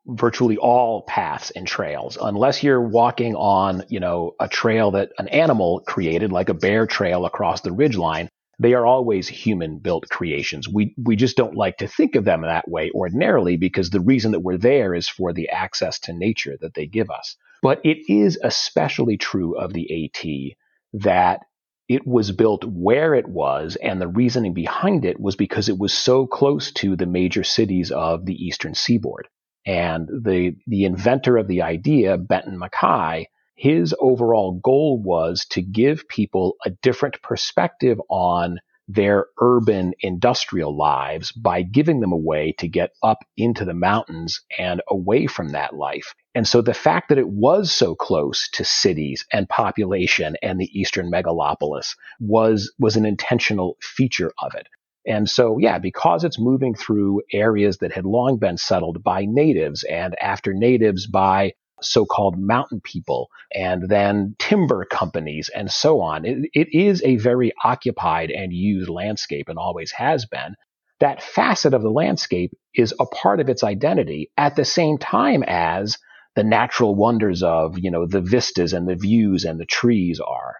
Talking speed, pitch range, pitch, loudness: 170 wpm, 90-120 Hz, 105 Hz, -20 LUFS